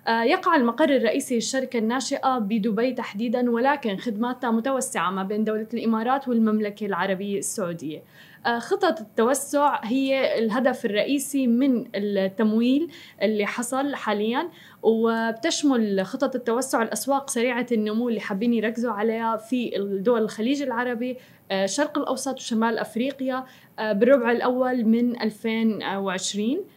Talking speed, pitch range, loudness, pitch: 110 wpm, 220-265 Hz, -24 LUFS, 235 Hz